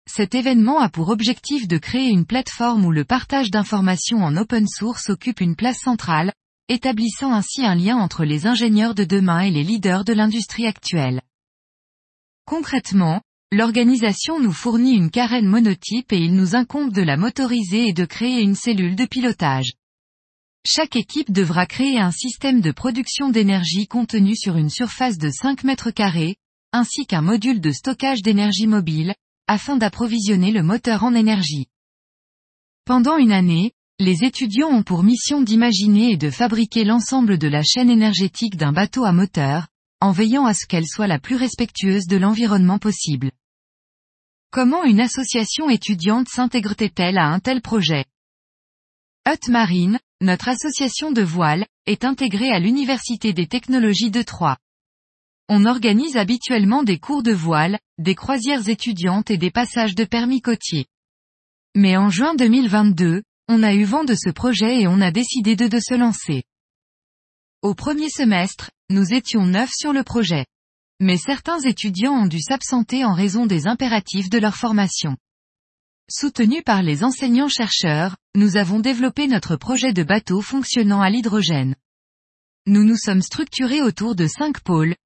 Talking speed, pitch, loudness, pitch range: 155 wpm, 220 Hz, -18 LUFS, 185-245 Hz